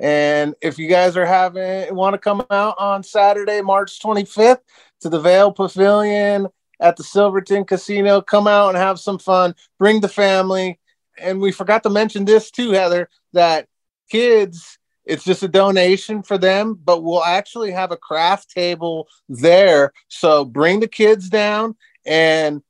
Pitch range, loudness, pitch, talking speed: 175-205 Hz, -16 LUFS, 195 Hz, 160 wpm